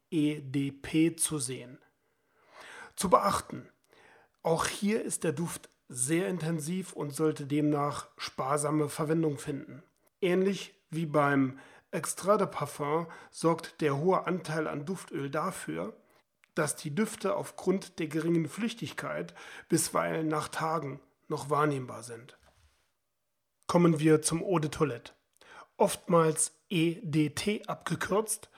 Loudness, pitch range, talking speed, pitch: -31 LUFS, 150-175 Hz, 110 wpm, 160 Hz